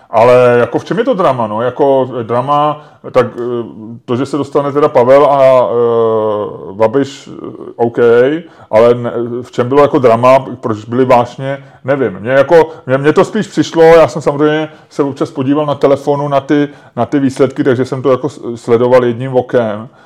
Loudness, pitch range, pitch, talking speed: -11 LUFS, 120-150 Hz, 135 Hz, 175 wpm